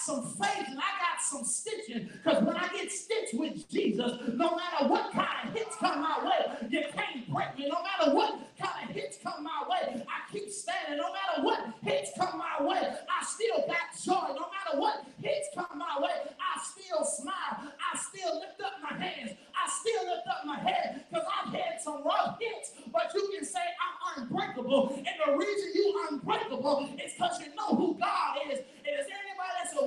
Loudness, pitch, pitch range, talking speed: -32 LUFS, 340 Hz, 290-370 Hz, 205 wpm